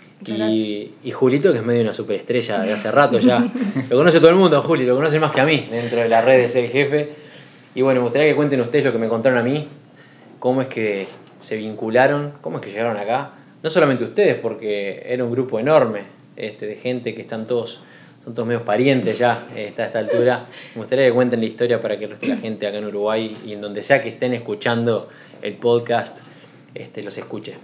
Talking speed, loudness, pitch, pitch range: 225 wpm, -19 LUFS, 120 Hz, 115-140 Hz